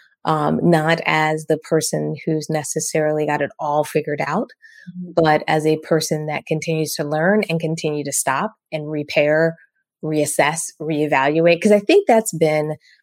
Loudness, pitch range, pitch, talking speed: -19 LUFS, 150-165 Hz, 155 Hz, 150 wpm